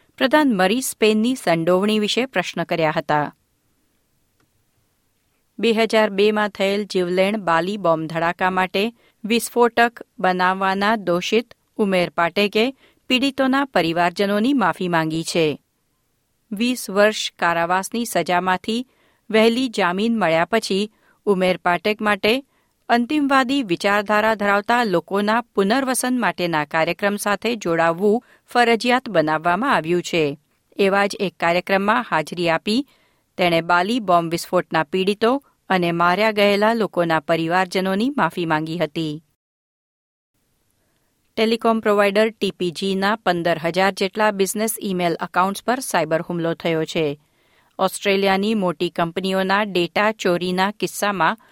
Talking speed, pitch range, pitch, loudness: 105 wpm, 175-220 Hz, 195 Hz, -20 LUFS